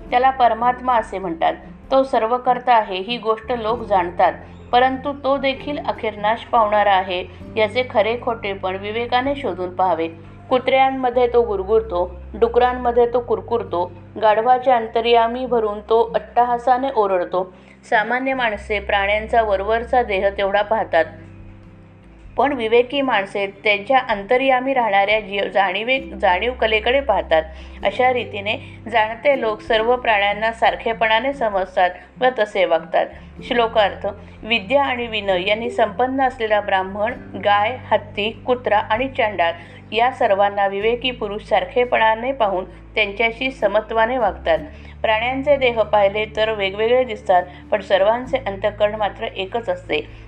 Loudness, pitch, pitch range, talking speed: -19 LUFS, 220 Hz, 200-250 Hz, 120 wpm